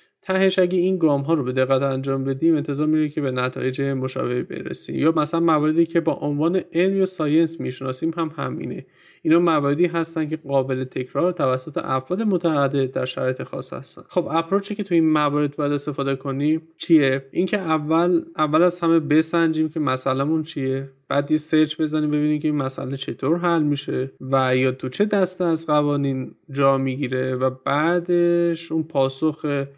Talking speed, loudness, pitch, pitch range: 170 wpm, -22 LUFS, 155 Hz, 135-165 Hz